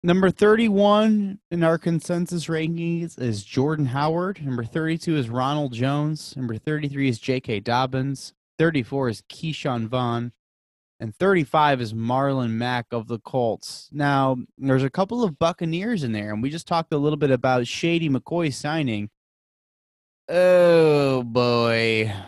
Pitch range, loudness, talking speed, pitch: 125-165 Hz, -22 LUFS, 140 wpm, 140 Hz